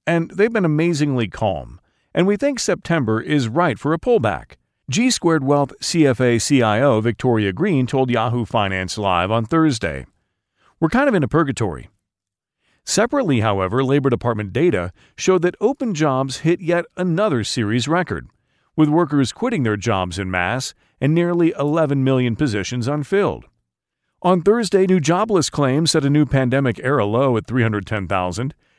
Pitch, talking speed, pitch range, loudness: 135 Hz, 150 wpm, 110-165 Hz, -19 LUFS